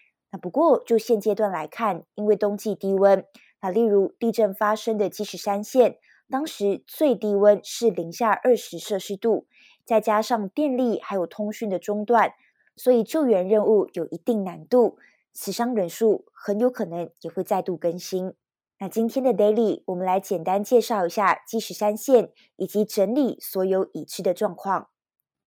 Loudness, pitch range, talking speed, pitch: -23 LUFS, 190-230 Hz, 260 characters per minute, 210 Hz